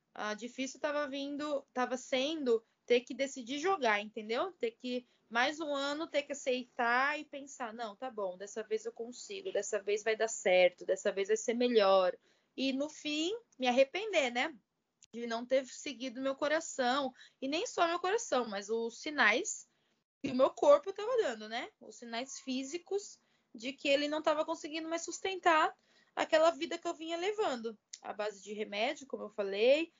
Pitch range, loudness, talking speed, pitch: 230-315 Hz, -34 LUFS, 180 wpm, 270 Hz